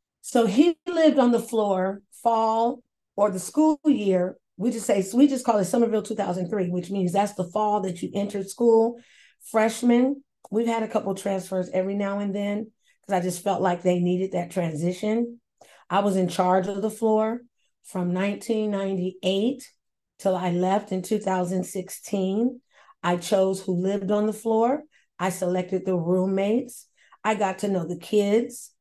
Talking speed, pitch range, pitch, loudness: 165 wpm, 185-230 Hz, 200 Hz, -24 LUFS